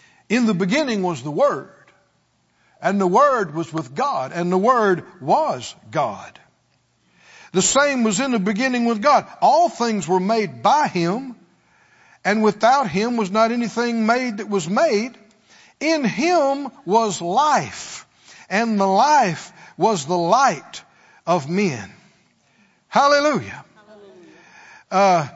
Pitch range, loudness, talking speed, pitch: 190-250 Hz, -19 LUFS, 130 wpm, 220 Hz